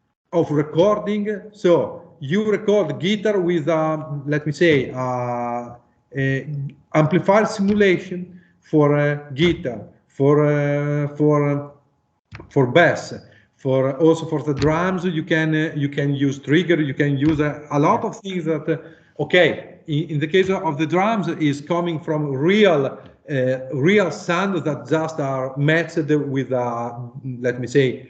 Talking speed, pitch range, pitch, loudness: 145 wpm, 140-170 Hz, 150 Hz, -20 LUFS